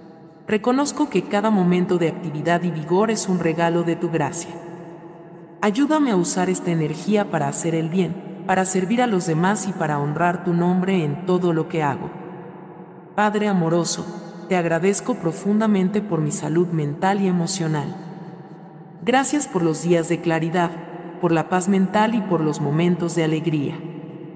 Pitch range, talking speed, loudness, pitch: 165-190 Hz, 160 wpm, -21 LUFS, 175 Hz